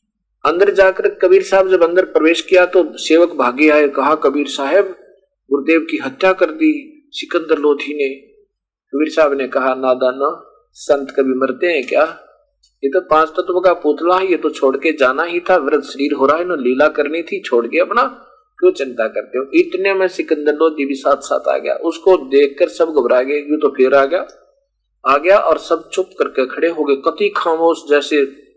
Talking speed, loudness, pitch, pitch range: 205 wpm, -15 LUFS, 165 Hz, 145-190 Hz